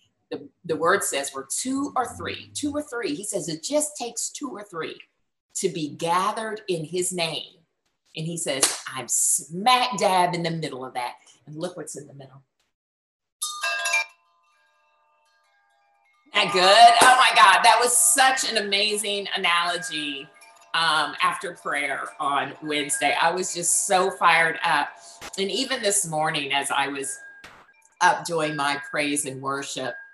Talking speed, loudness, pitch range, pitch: 155 wpm, -22 LUFS, 140-215 Hz, 170 Hz